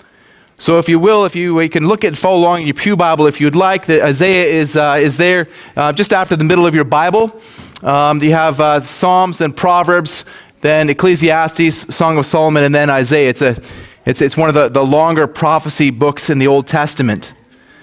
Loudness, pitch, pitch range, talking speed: -12 LUFS, 155 Hz, 145-175 Hz, 210 wpm